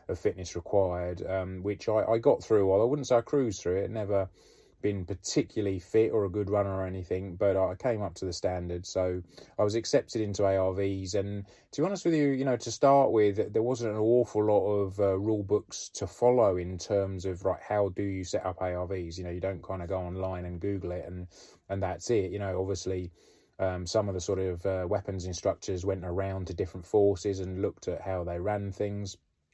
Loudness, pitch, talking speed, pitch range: -30 LUFS, 95 Hz, 225 wpm, 95-105 Hz